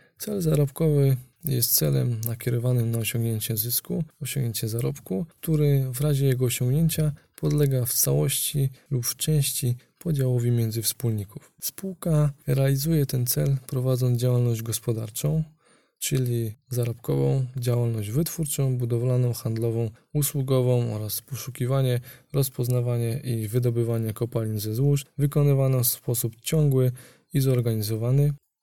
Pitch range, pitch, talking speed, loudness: 120-145 Hz, 130 Hz, 110 wpm, -25 LUFS